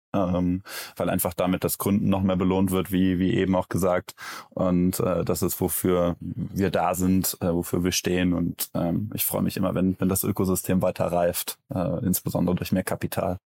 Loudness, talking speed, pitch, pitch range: -25 LUFS, 195 wpm, 90 Hz, 90-95 Hz